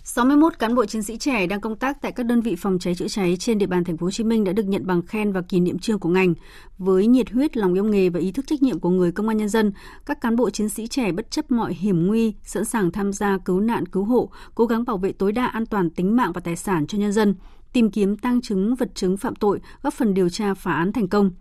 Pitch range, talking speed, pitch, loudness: 185-230 Hz, 290 wpm, 210 Hz, -22 LUFS